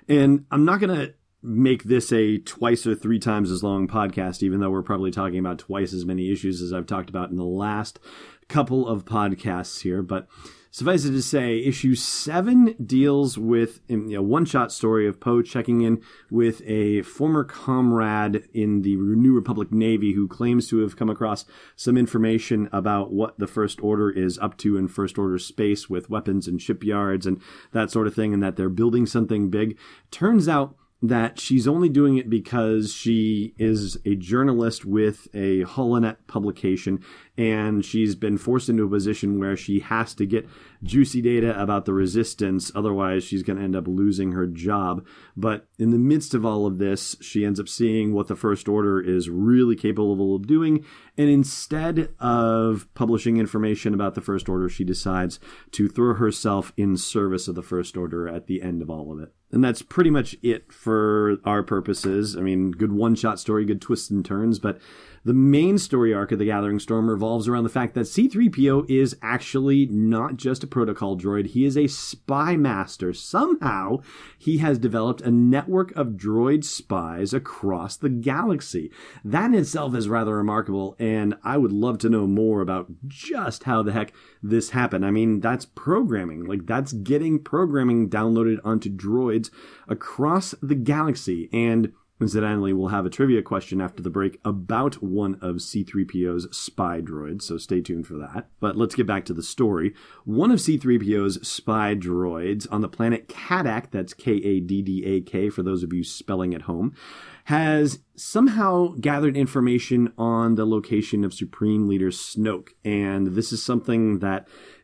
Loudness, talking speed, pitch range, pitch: -23 LUFS, 180 wpm, 95-120 Hz, 110 Hz